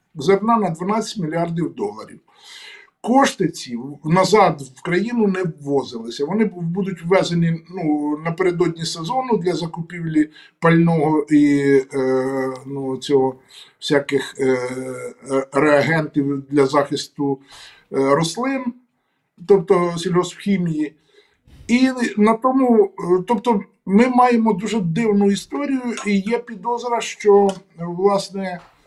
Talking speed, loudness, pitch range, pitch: 100 wpm, -19 LUFS, 145-215 Hz, 180 Hz